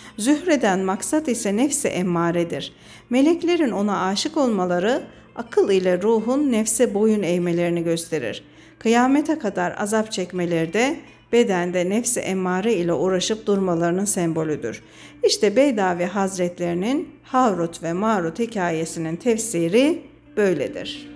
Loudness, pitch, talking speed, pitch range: -21 LUFS, 200 Hz, 105 wpm, 175-255 Hz